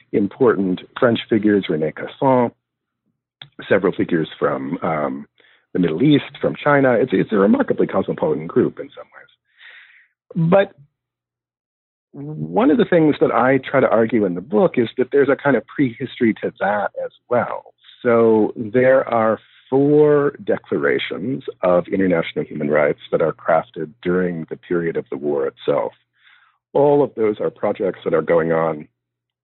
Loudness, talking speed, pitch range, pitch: -18 LUFS, 155 wpm, 100-145 Hz, 125 Hz